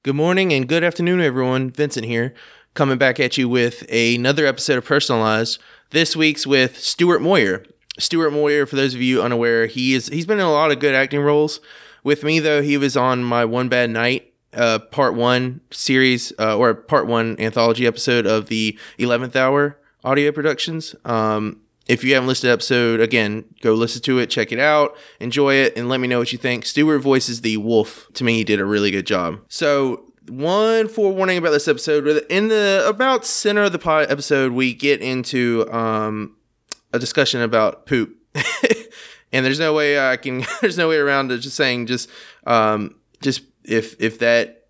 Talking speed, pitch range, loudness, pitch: 190 wpm, 120-150 Hz, -18 LUFS, 130 Hz